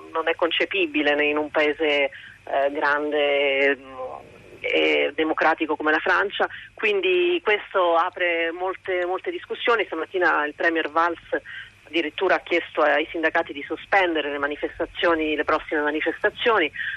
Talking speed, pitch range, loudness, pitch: 120 wpm, 150-180 Hz, -22 LUFS, 160 Hz